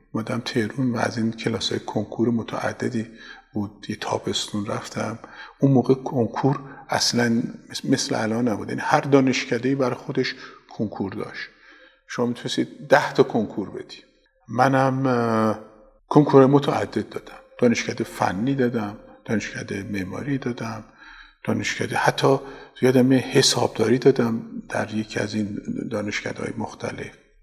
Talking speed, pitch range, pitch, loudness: 120 wpm, 110-130 Hz, 120 Hz, -23 LUFS